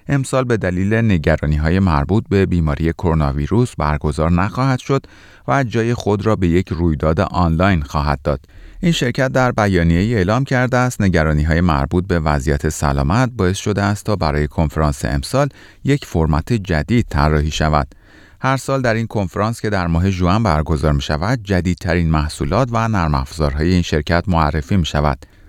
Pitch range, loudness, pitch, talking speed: 80-110 Hz, -17 LUFS, 90 Hz, 165 wpm